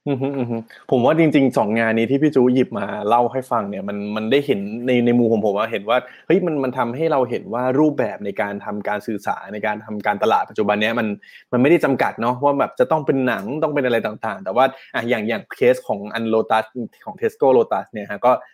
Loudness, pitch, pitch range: -20 LUFS, 120 Hz, 105-135 Hz